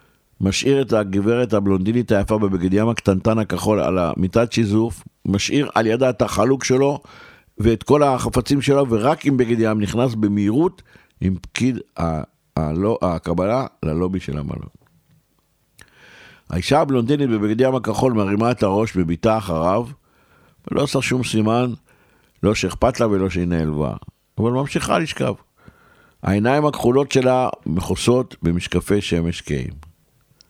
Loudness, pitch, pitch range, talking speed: -19 LUFS, 110 Hz, 95-125 Hz, 120 wpm